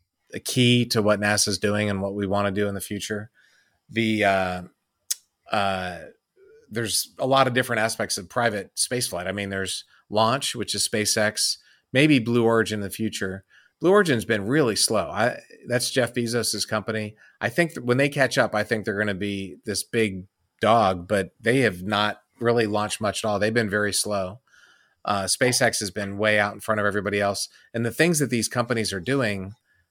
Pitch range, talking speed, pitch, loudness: 100-120 Hz, 200 wpm, 105 Hz, -23 LUFS